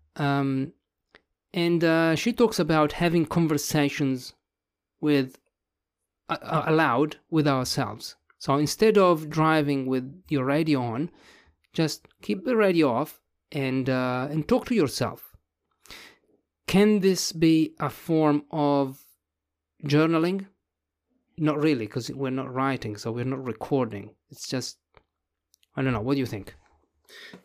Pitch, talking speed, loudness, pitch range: 145 Hz, 130 wpm, -25 LUFS, 130-160 Hz